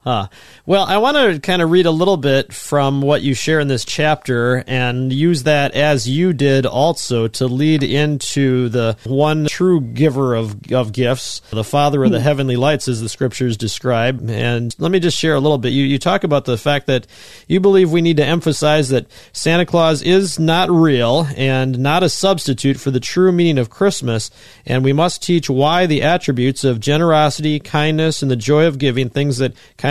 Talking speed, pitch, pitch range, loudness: 200 wpm, 140 Hz, 125-160 Hz, -15 LUFS